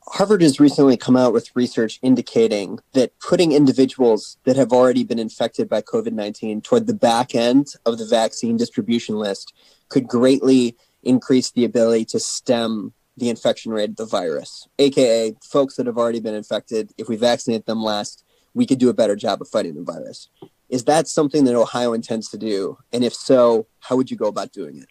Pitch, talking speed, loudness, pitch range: 120 Hz, 195 wpm, -19 LUFS, 115-135 Hz